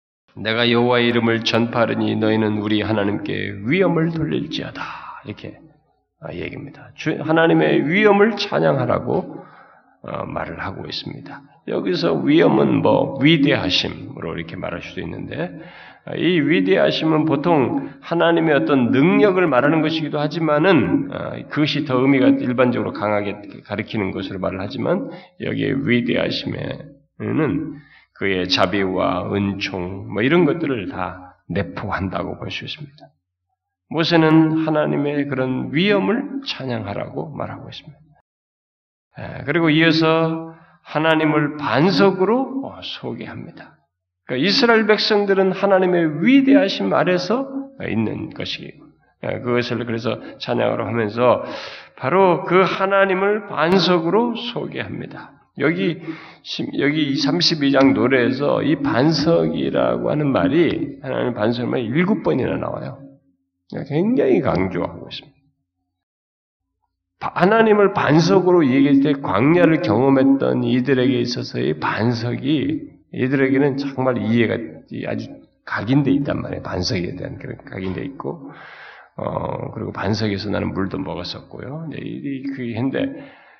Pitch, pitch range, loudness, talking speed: 140 Hz, 110-165 Hz, -19 LUFS, 285 characters per minute